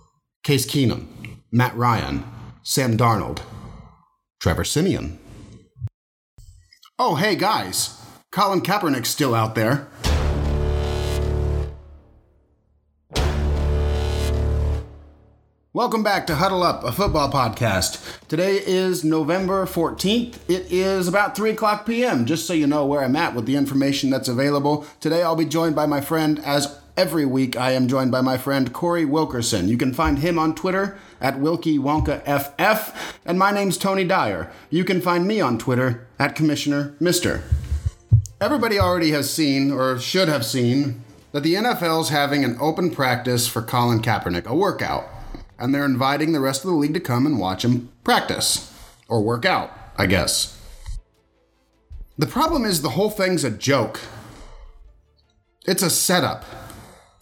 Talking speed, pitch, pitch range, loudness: 145 wpm, 140 Hz, 110-165 Hz, -21 LUFS